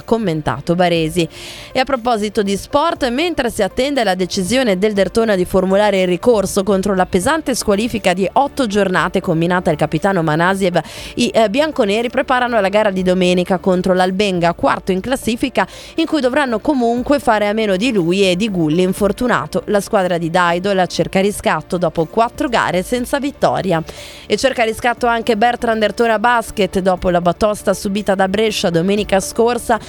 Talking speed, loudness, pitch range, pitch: 160 wpm, -16 LUFS, 180-235 Hz, 200 Hz